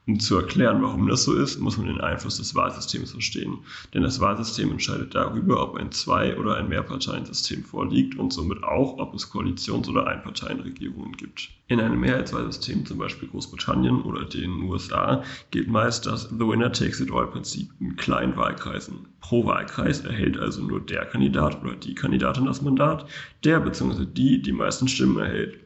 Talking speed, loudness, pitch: 175 wpm, -25 LUFS, 100 Hz